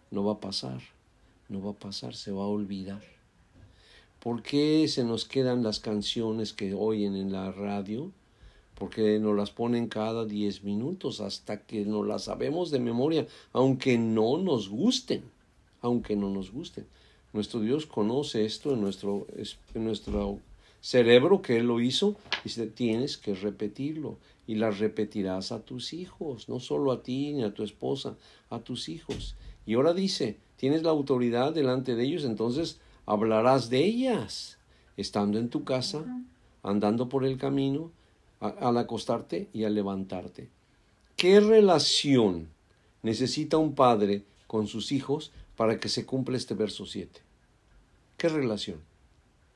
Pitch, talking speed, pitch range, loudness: 110 Hz, 150 wpm, 105-130 Hz, -29 LUFS